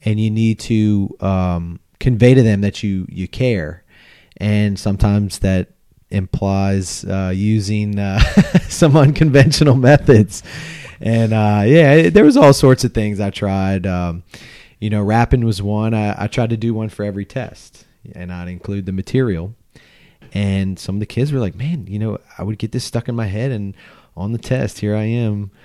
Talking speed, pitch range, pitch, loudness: 180 wpm, 95-120 Hz, 105 Hz, -16 LUFS